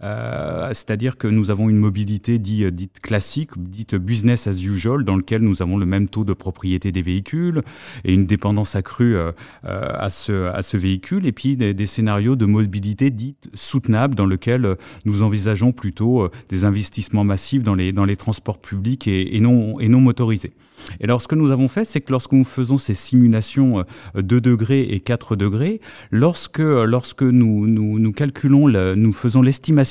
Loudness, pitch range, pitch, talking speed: -19 LUFS, 100-125 Hz, 110 Hz, 195 wpm